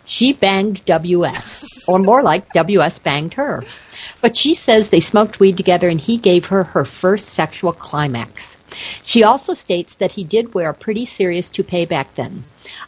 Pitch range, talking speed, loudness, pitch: 175-220 Hz, 170 wpm, -15 LUFS, 190 Hz